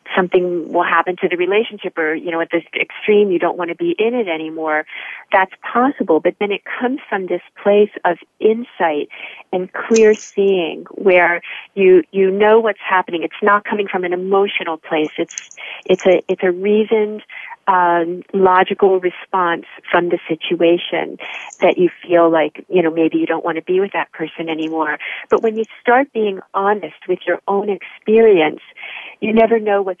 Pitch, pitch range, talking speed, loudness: 185 Hz, 170-205 Hz, 180 wpm, -16 LUFS